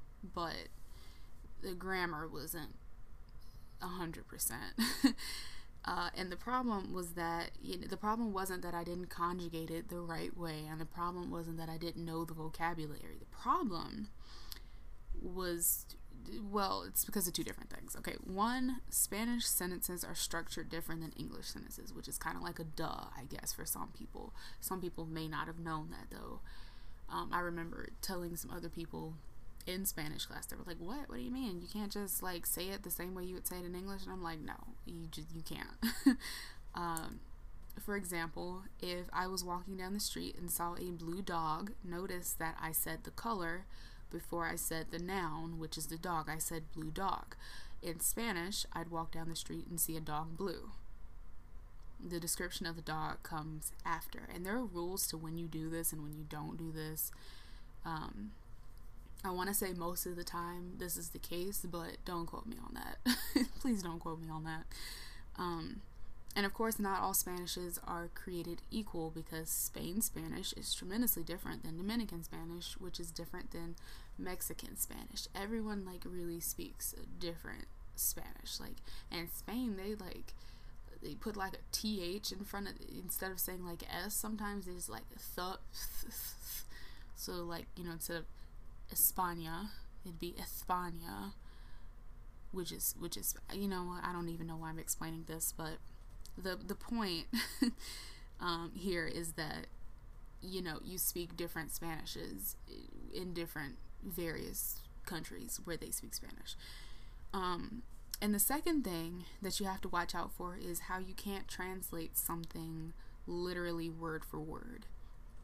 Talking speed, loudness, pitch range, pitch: 175 wpm, -41 LUFS, 160-190 Hz, 175 Hz